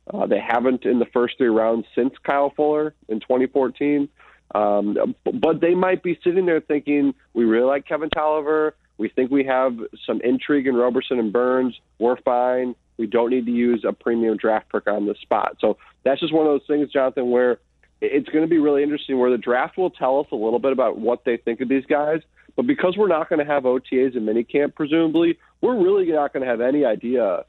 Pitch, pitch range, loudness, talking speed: 135 Hz, 120-155 Hz, -21 LUFS, 220 wpm